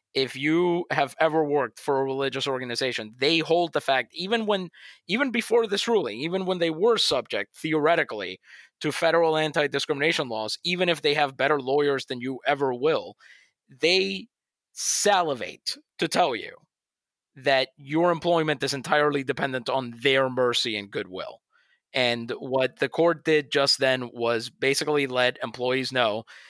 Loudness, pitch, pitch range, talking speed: -25 LUFS, 145 Hz, 130-170 Hz, 155 wpm